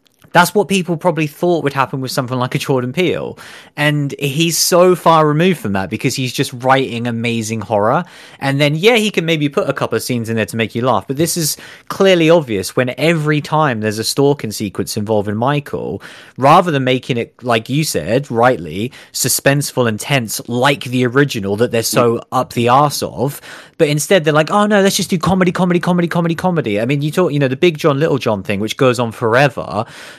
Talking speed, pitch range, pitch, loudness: 215 wpm, 120-165 Hz, 140 Hz, -15 LUFS